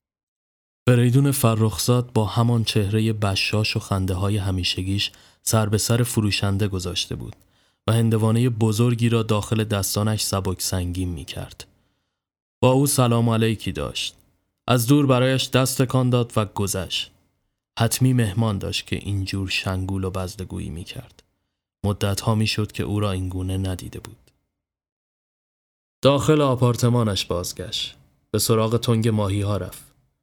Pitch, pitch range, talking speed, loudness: 105 Hz, 95-120 Hz, 135 wpm, -22 LUFS